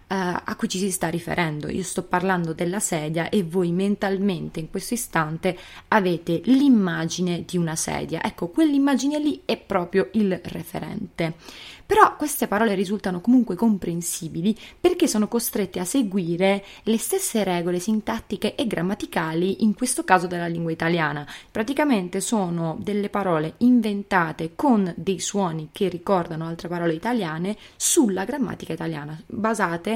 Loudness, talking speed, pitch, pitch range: -23 LUFS, 140 wpm, 190 Hz, 175-220 Hz